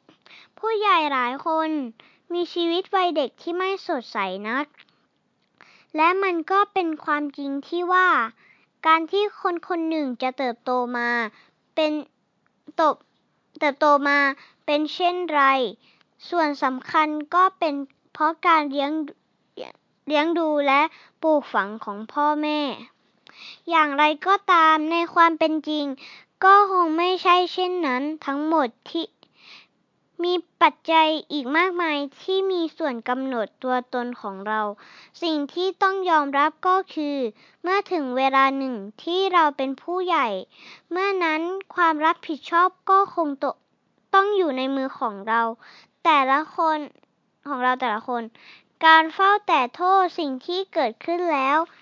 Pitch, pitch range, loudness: 310 Hz, 270-350 Hz, -22 LUFS